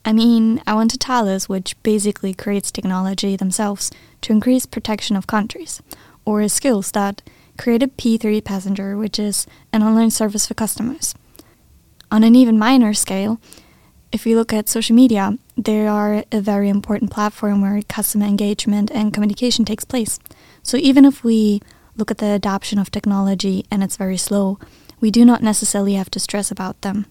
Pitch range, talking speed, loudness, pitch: 200-225 Hz, 175 wpm, -17 LUFS, 210 Hz